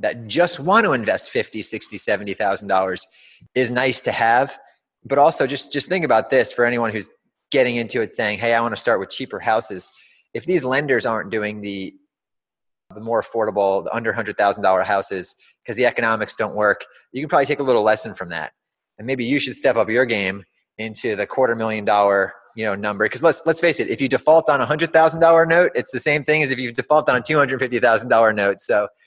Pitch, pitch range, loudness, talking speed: 120 Hz, 105-150 Hz, -19 LUFS, 230 wpm